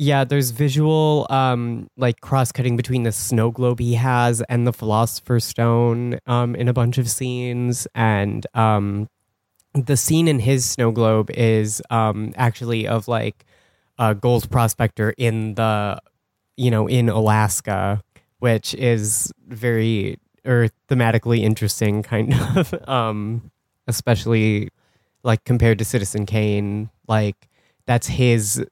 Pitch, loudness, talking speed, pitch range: 115 Hz, -20 LUFS, 130 wpm, 110-125 Hz